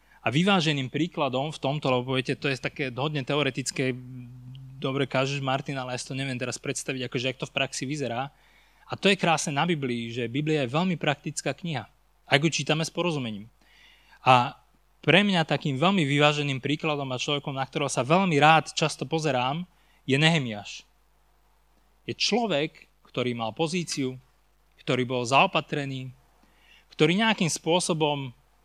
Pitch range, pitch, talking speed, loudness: 130-155 Hz, 145 Hz, 155 wpm, -26 LUFS